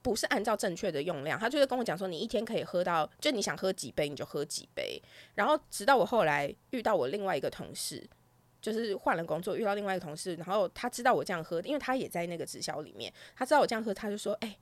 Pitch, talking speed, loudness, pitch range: 205 Hz, 395 characters per minute, -32 LUFS, 175-250 Hz